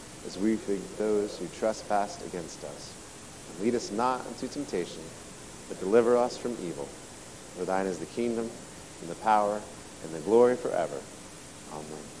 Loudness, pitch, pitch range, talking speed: -30 LUFS, 105 Hz, 95-120 Hz, 155 wpm